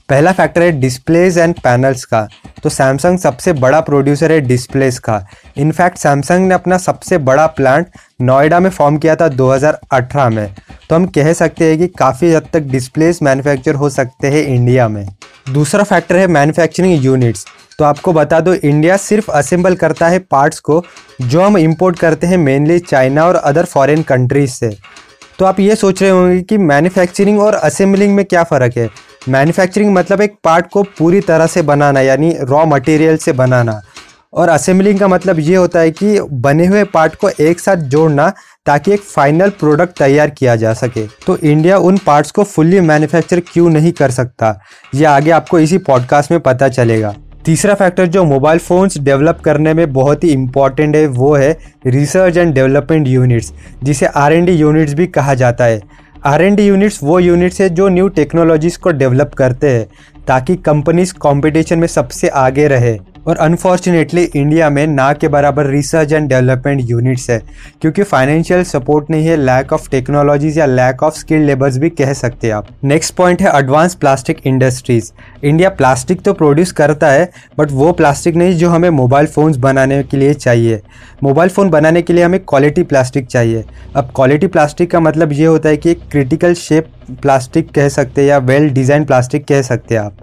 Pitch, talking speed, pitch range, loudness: 150 Hz, 185 wpm, 135-175 Hz, -11 LUFS